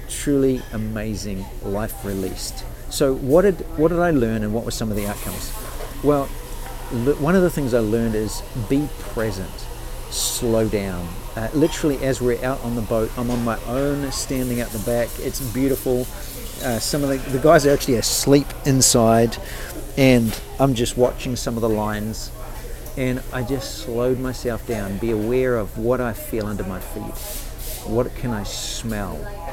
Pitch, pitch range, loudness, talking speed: 120 Hz, 110-135 Hz, -21 LUFS, 175 wpm